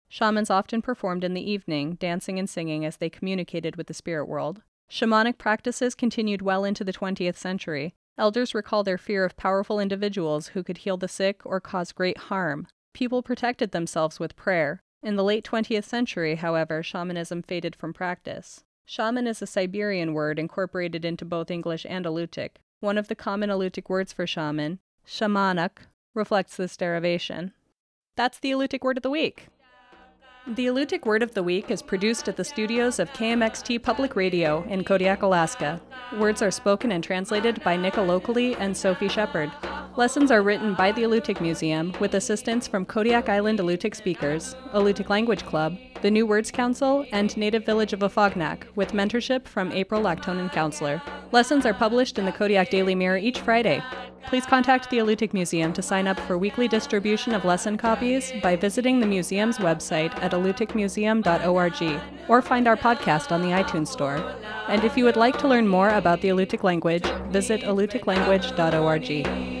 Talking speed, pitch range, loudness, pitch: 170 wpm, 180-225 Hz, -25 LUFS, 195 Hz